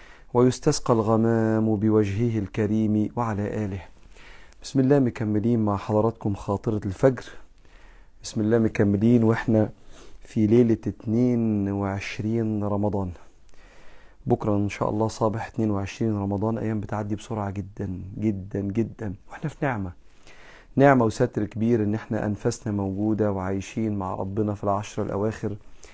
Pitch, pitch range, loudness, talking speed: 105 Hz, 100-115 Hz, -25 LUFS, 115 wpm